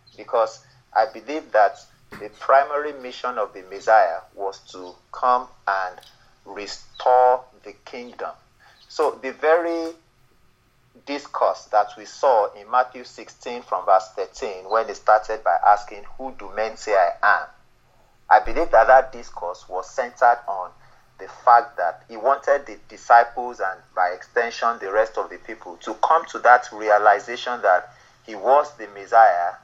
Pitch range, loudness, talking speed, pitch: 105-125 Hz, -20 LUFS, 150 wpm, 120 Hz